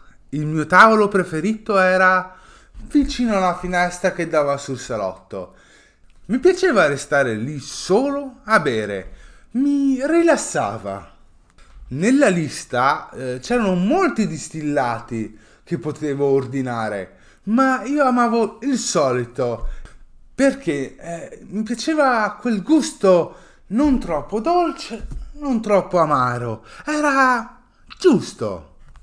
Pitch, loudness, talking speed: 190 Hz, -19 LUFS, 100 wpm